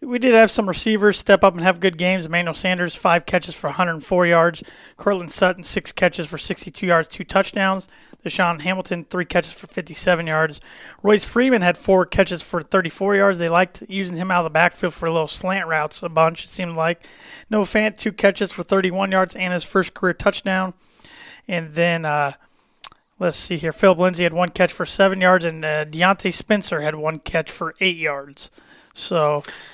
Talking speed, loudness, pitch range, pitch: 195 wpm, -19 LUFS, 170-195 Hz, 180 Hz